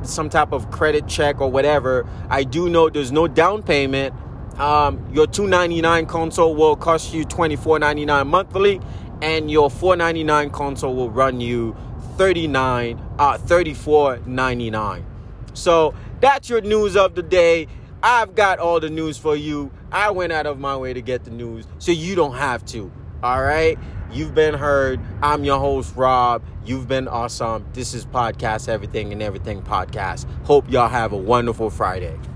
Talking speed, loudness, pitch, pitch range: 160 wpm, -19 LUFS, 140 Hz, 120-160 Hz